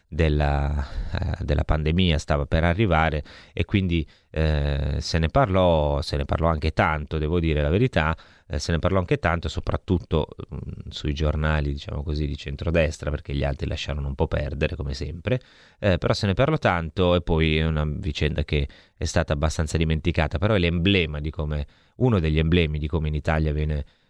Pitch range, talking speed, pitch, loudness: 75-90 Hz, 185 wpm, 80 Hz, -24 LUFS